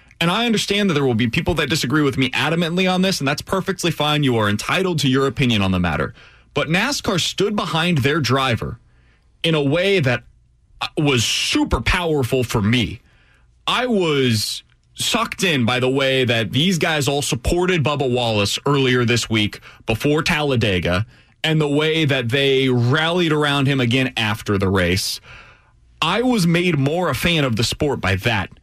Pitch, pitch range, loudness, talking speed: 140 Hz, 115-165 Hz, -18 LUFS, 180 wpm